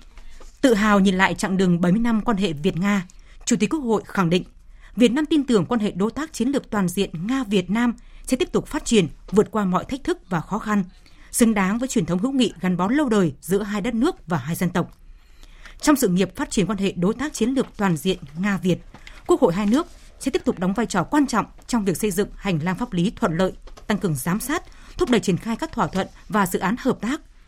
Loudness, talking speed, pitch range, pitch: -22 LUFS, 260 wpm, 190-245 Hz, 210 Hz